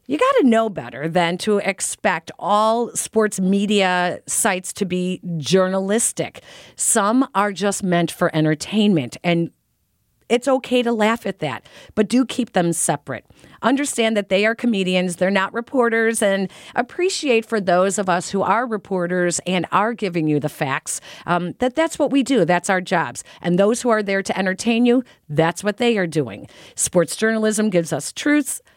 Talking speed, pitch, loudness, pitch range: 170 wpm, 195 Hz, -19 LUFS, 175-225 Hz